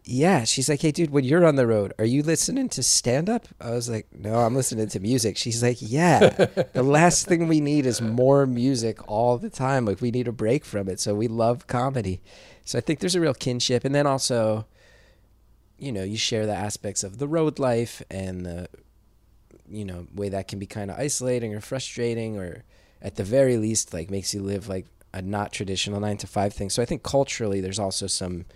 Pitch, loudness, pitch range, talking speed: 115 Hz, -24 LUFS, 100-135 Hz, 225 wpm